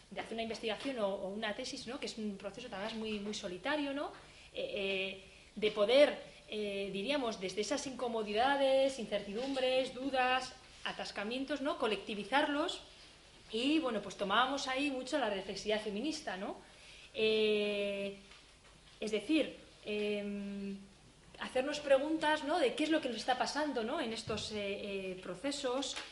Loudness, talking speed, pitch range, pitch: -36 LUFS, 140 wpm, 205-275 Hz, 225 Hz